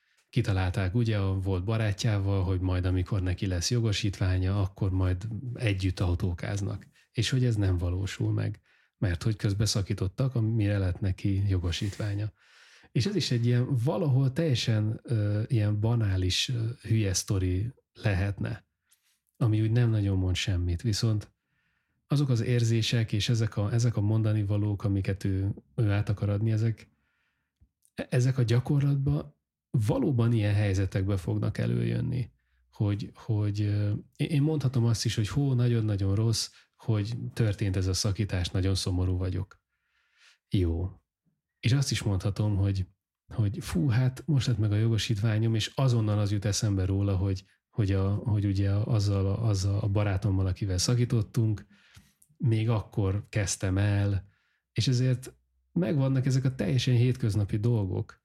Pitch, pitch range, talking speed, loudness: 105 Hz, 95-115 Hz, 140 wpm, -28 LUFS